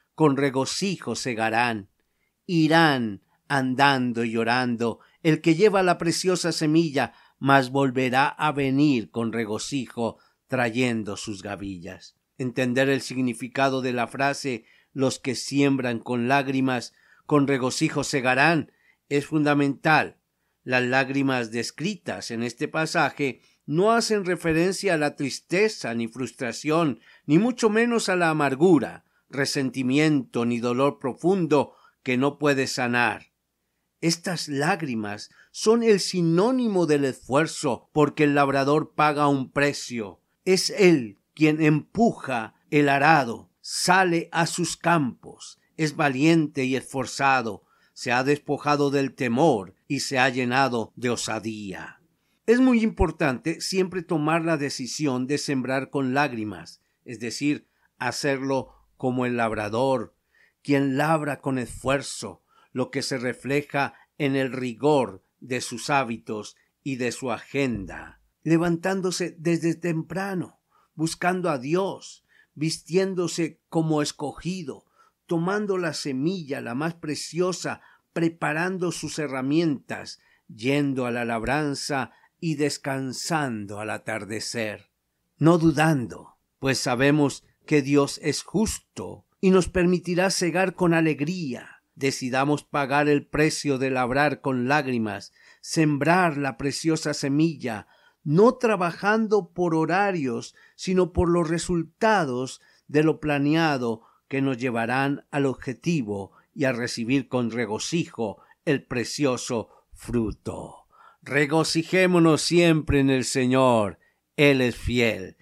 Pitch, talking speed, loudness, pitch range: 140 Hz, 115 wpm, -24 LUFS, 125-165 Hz